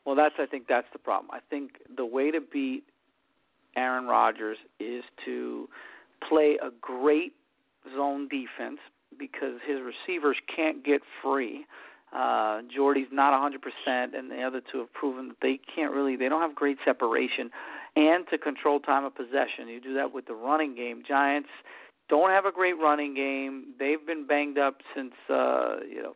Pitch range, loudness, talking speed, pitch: 130-150 Hz, -28 LUFS, 175 wpm, 140 Hz